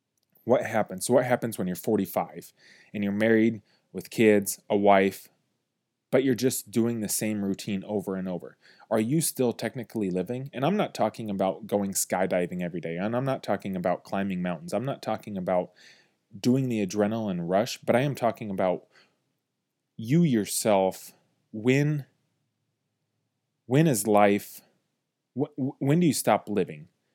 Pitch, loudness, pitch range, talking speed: 110 Hz, -27 LUFS, 100-130 Hz, 155 wpm